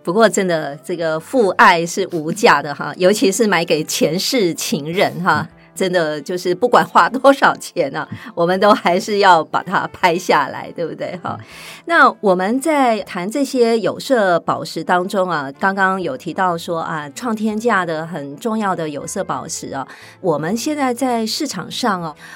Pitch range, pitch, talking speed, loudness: 170-230 Hz, 185 Hz, 240 characters per minute, -17 LUFS